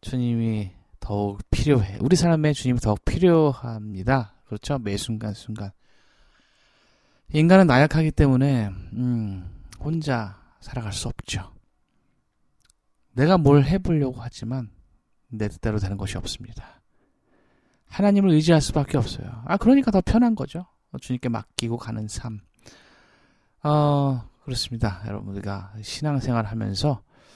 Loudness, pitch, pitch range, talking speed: -23 LUFS, 120 Hz, 105-145 Hz, 270 characters per minute